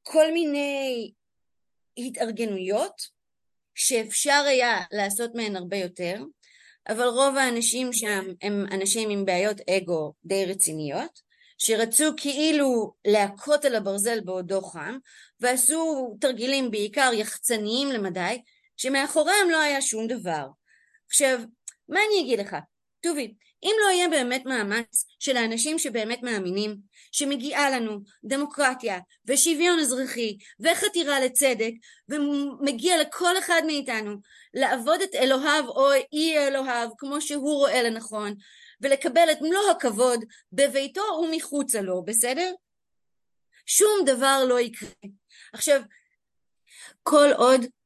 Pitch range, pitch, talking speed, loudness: 220-295 Hz, 255 Hz, 110 wpm, -24 LUFS